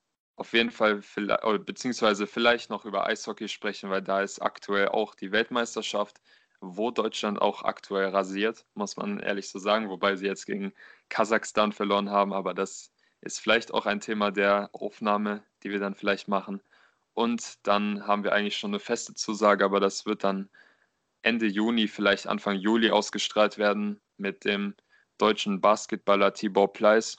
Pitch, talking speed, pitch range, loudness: 105 Hz, 160 wpm, 100-110 Hz, -27 LUFS